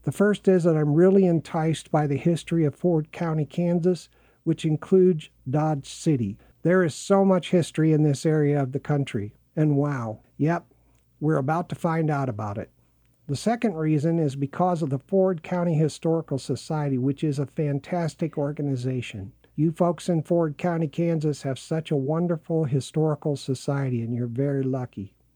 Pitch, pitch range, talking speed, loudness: 155 Hz, 140-170 Hz, 170 wpm, -25 LUFS